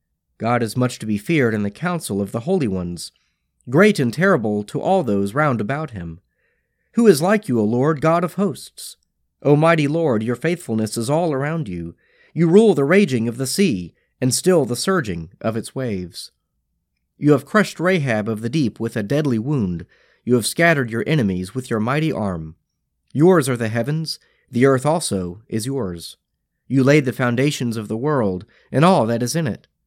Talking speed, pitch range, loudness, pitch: 195 wpm, 110-160 Hz, -19 LUFS, 125 Hz